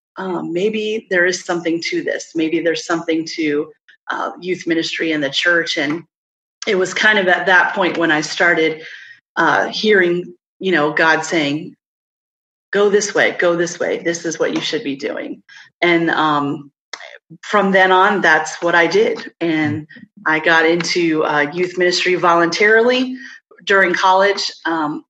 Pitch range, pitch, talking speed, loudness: 160-195 Hz, 175 Hz, 160 wpm, -16 LUFS